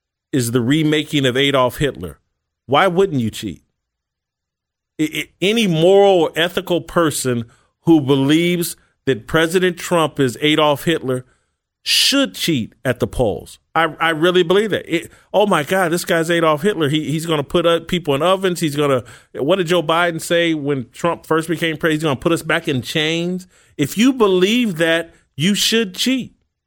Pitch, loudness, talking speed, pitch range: 160 Hz, -17 LUFS, 180 wpm, 140-180 Hz